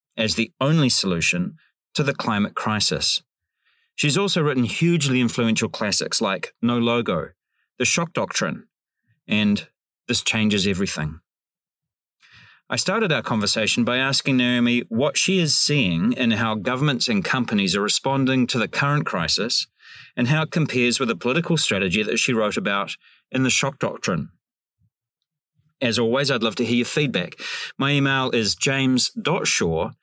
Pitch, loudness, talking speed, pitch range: 125 Hz, -21 LUFS, 150 wpm, 115-150 Hz